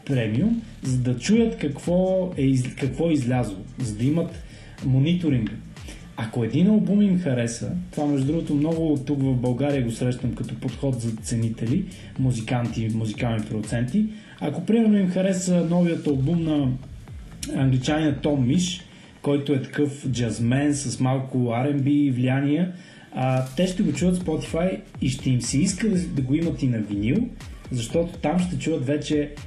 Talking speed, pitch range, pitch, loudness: 150 wpm, 125-165 Hz, 140 Hz, -24 LUFS